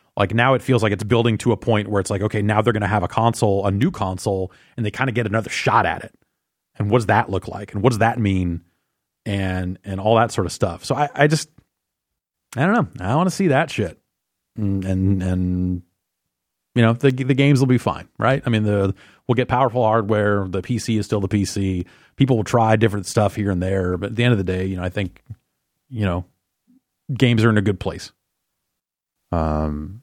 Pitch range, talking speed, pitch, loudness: 95-120 Hz, 235 wpm, 105 Hz, -20 LUFS